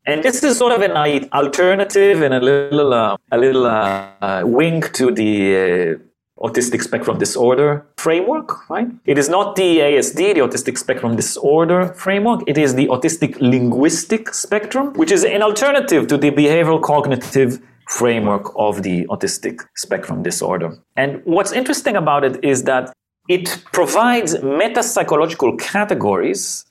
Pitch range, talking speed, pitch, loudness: 130-210 Hz, 145 wpm, 155 Hz, -16 LUFS